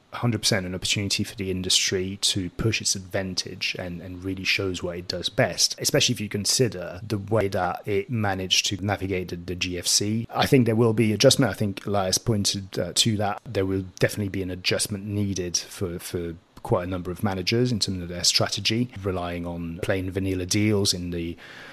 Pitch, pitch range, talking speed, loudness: 100 Hz, 90-110 Hz, 195 wpm, -24 LUFS